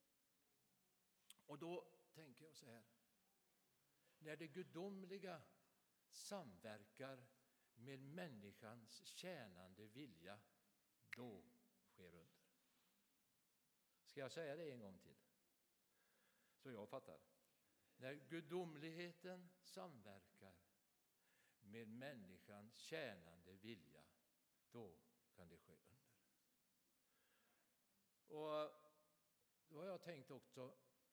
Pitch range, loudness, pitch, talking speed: 115-175 Hz, -58 LUFS, 150 Hz, 85 wpm